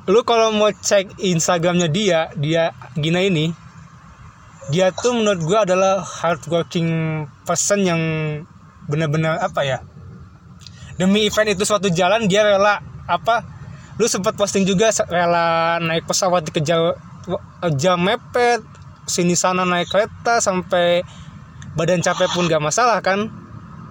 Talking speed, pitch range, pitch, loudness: 125 wpm, 160-200 Hz, 175 Hz, -18 LUFS